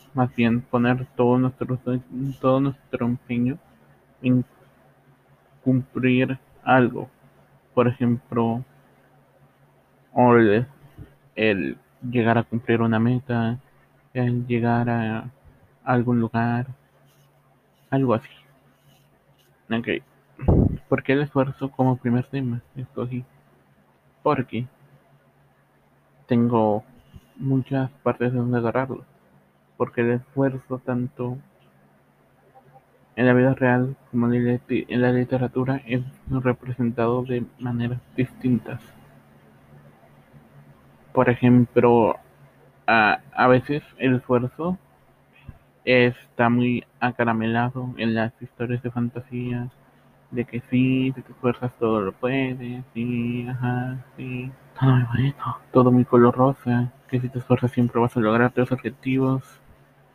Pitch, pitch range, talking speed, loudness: 125 Hz, 120-130 Hz, 105 wpm, -23 LUFS